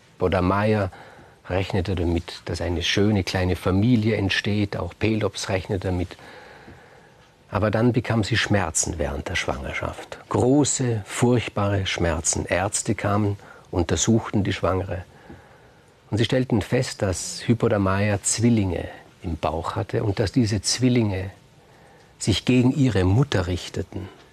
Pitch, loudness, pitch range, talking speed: 105 Hz, -23 LUFS, 95-115 Hz, 120 wpm